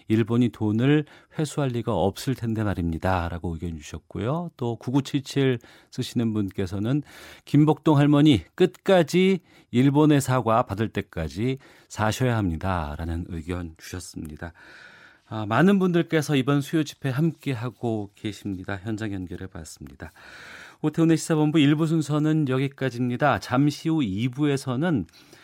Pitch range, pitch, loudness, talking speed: 100-150 Hz, 125 Hz, -24 LUFS, 290 characters per minute